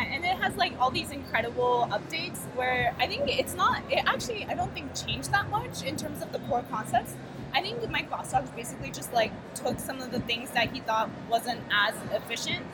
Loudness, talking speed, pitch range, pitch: -29 LUFS, 215 wpm, 235-260 Hz, 245 Hz